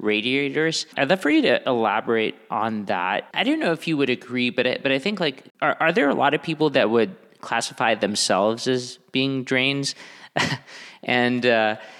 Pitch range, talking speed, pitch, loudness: 125-155 Hz, 190 wpm, 130 Hz, -22 LUFS